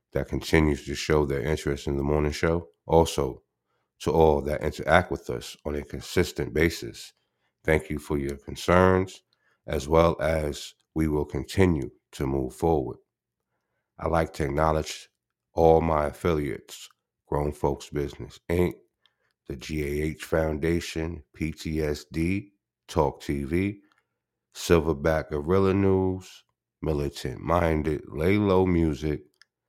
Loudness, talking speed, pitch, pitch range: -26 LUFS, 120 wpm, 80 Hz, 70-85 Hz